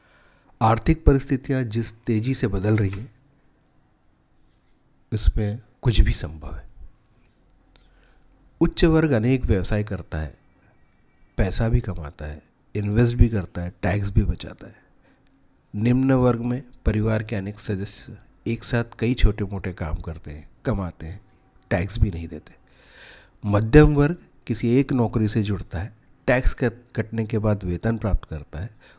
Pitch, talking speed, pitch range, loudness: 110 Hz, 145 wpm, 95-120 Hz, -23 LUFS